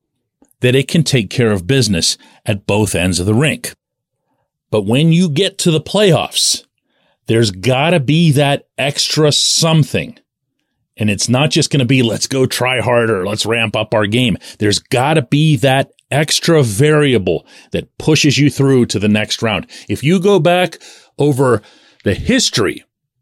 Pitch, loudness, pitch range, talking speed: 135 Hz, -14 LUFS, 115-155 Hz, 160 wpm